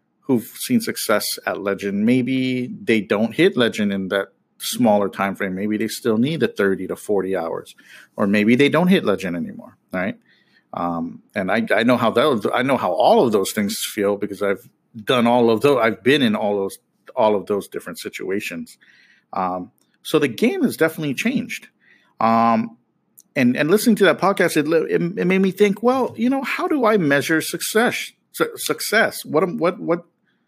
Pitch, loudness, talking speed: 130 Hz, -19 LUFS, 190 wpm